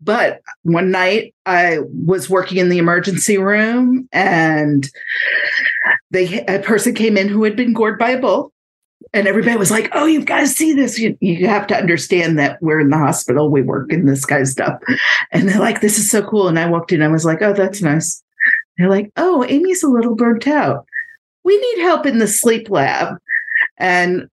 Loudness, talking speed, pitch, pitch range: -15 LUFS, 205 wpm, 210 Hz, 175-250 Hz